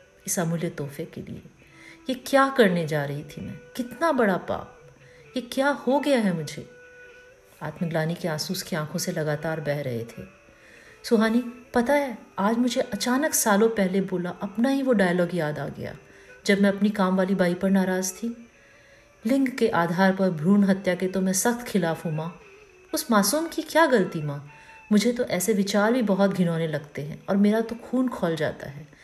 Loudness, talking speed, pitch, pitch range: -24 LUFS, 185 wpm, 195 Hz, 170-245 Hz